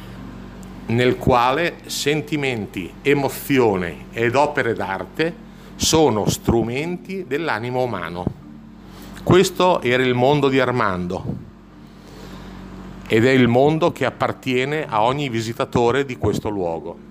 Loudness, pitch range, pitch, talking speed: -19 LUFS, 115-150 Hz, 130 Hz, 100 wpm